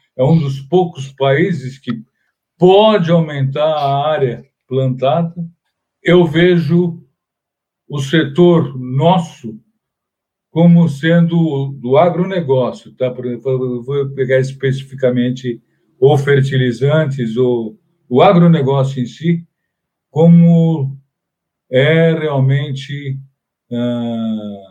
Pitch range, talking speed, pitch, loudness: 130-170 Hz, 90 wpm, 145 Hz, -14 LUFS